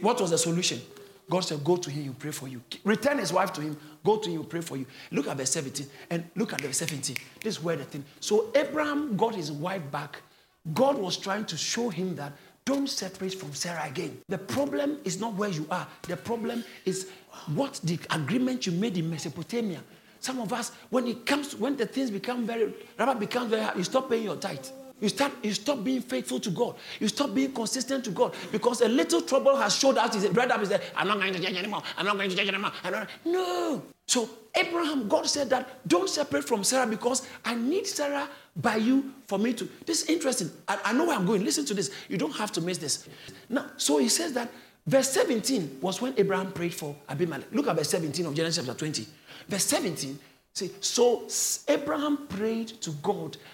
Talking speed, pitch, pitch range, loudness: 225 wpm, 210 Hz, 170-260 Hz, -28 LUFS